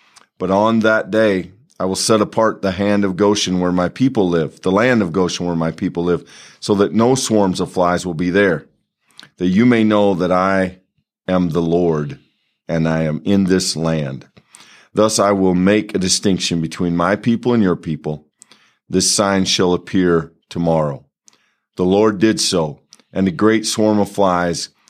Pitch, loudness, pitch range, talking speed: 95 Hz, -16 LUFS, 85-105 Hz, 180 wpm